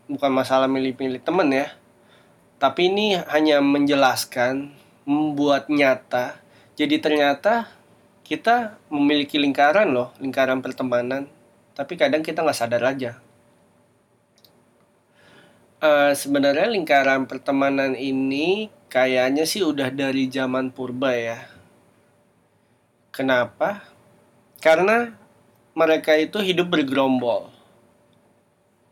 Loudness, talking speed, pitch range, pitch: -21 LUFS, 90 wpm, 130-150 Hz, 140 Hz